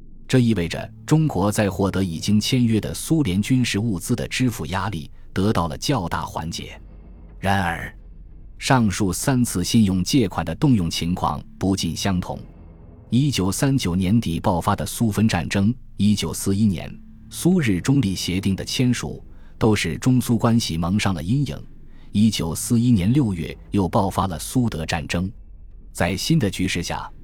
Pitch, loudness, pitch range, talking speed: 100 Hz, -21 LUFS, 85-115 Hz, 240 characters per minute